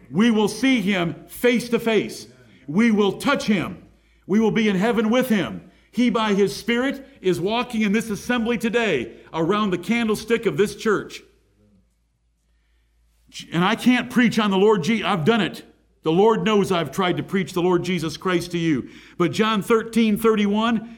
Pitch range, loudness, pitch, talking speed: 180-230 Hz, -21 LUFS, 210 Hz, 175 wpm